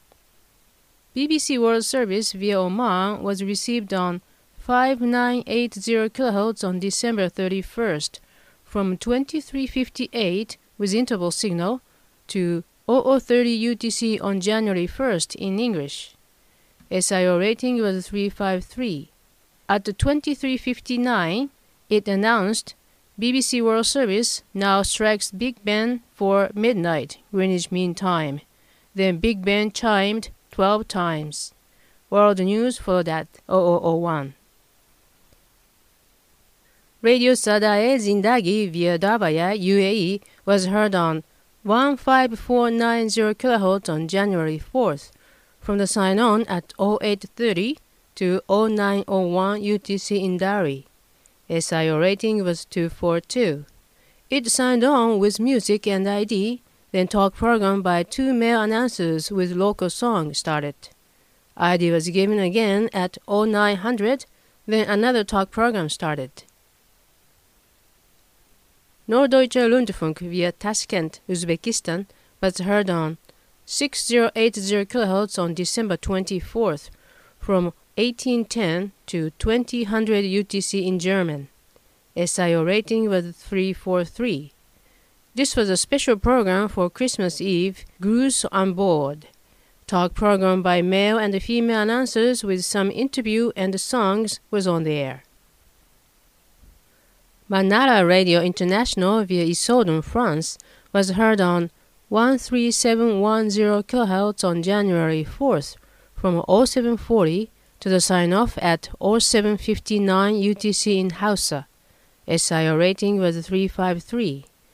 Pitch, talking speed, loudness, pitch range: 200 Hz, 110 wpm, -21 LUFS, 180-230 Hz